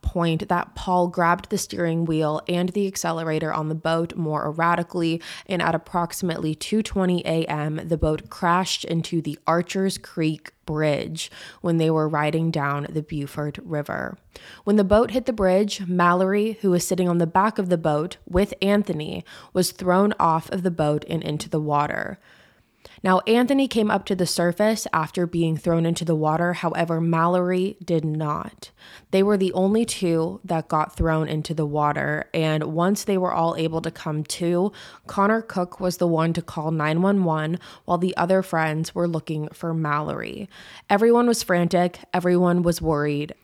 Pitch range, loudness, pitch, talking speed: 160-185 Hz, -23 LUFS, 170 Hz, 170 wpm